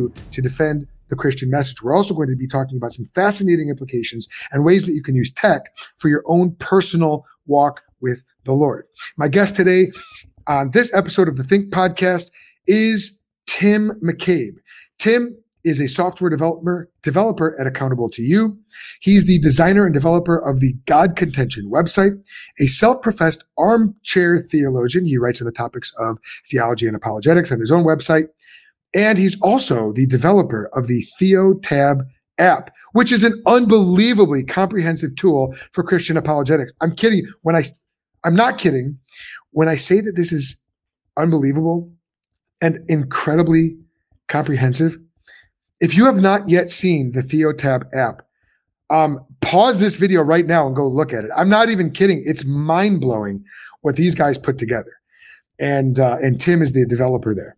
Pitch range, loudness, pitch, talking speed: 135-185 Hz, -17 LUFS, 160 Hz, 165 wpm